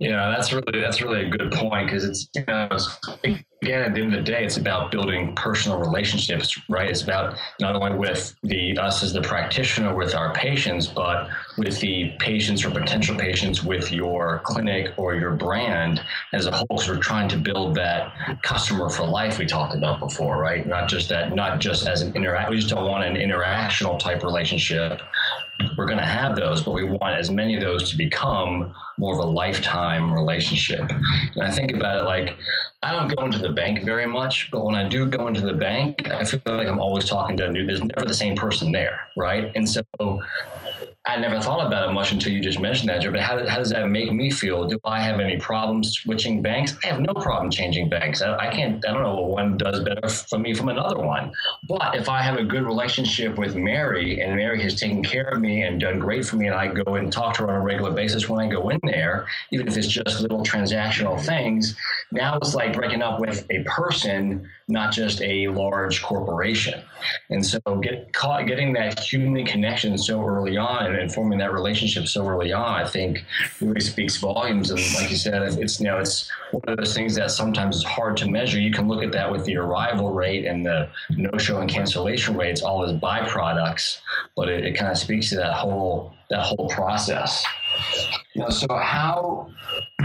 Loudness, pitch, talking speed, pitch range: -23 LUFS, 100 Hz, 215 wpm, 95-110 Hz